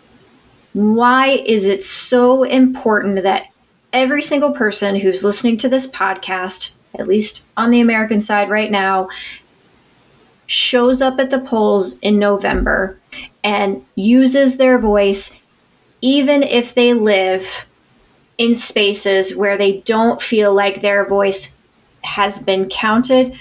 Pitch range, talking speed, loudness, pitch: 200-250 Hz, 125 wpm, -14 LUFS, 215 Hz